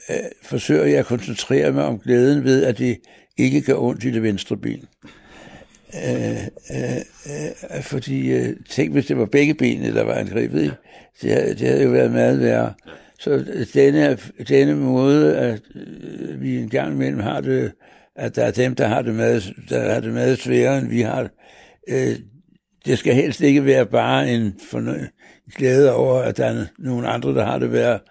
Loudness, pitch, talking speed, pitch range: -19 LUFS, 125 Hz, 180 wpm, 105-135 Hz